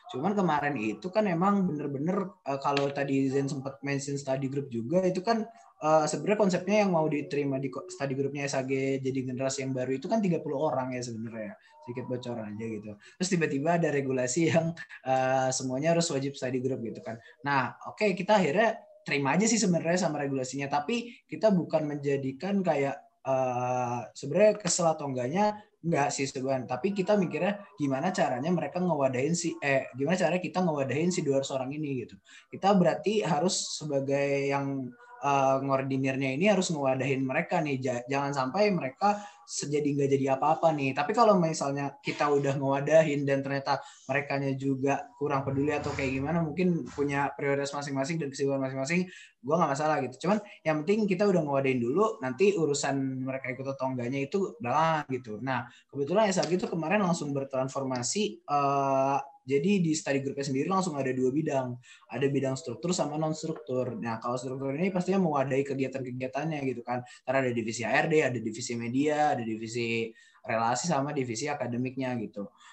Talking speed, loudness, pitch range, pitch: 165 wpm, -29 LUFS, 130-165 Hz, 140 Hz